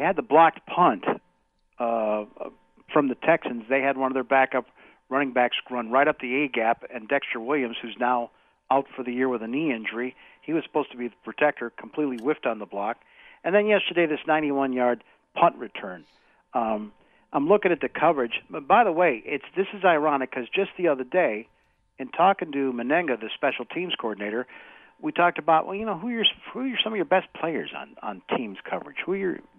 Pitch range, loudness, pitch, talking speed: 120-160 Hz, -25 LUFS, 135 Hz, 205 wpm